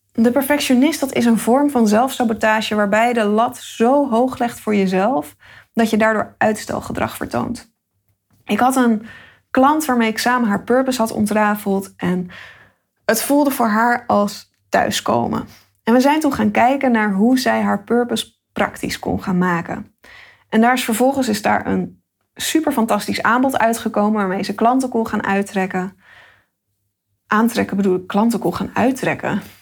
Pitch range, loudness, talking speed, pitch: 200-250 Hz, -17 LUFS, 160 wpm, 225 Hz